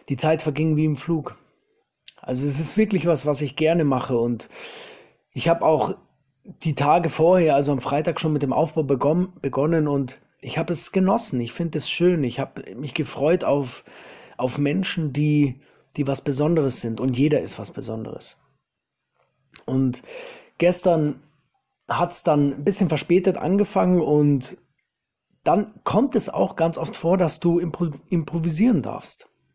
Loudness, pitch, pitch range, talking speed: -22 LUFS, 155 Hz, 140-175 Hz, 160 wpm